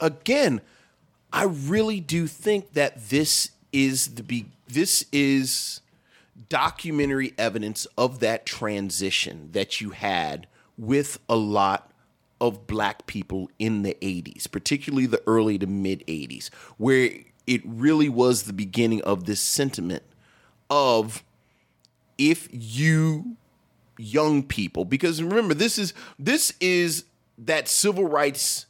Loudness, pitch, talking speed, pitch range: -24 LUFS, 130 Hz, 120 wpm, 105-155 Hz